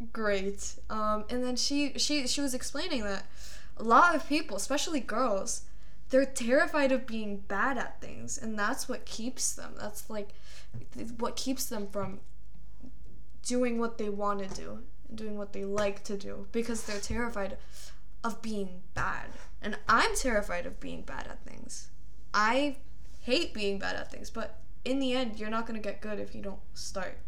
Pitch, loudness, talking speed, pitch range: 225 Hz, -32 LUFS, 180 wpm, 205-260 Hz